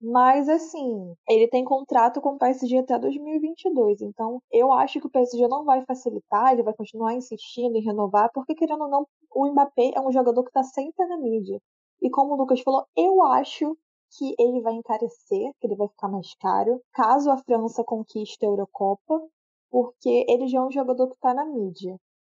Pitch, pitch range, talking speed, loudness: 255 Hz, 230-280 Hz, 195 wpm, -23 LUFS